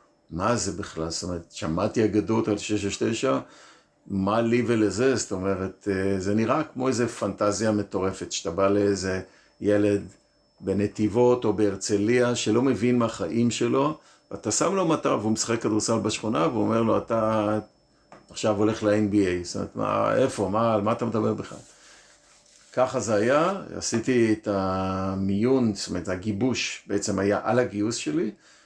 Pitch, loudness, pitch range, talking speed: 105 Hz, -25 LUFS, 100-115 Hz, 150 wpm